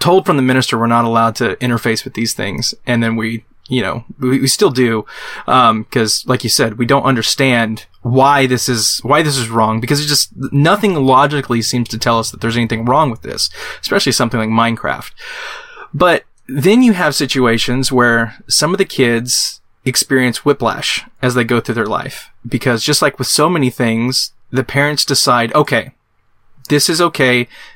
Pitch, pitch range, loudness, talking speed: 125 Hz, 115-135 Hz, -14 LUFS, 190 wpm